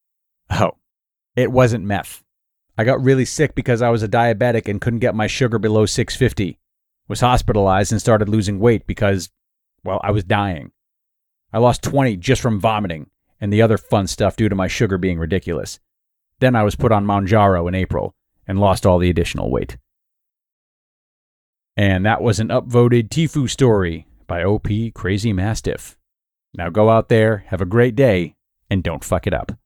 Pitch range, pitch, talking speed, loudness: 95-120 Hz, 105 Hz, 180 wpm, -18 LUFS